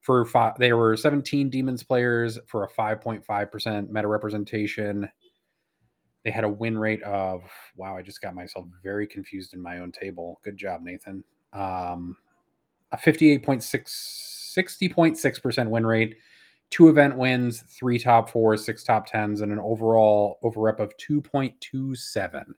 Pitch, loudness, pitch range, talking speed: 110 Hz, -24 LUFS, 105-130 Hz, 150 wpm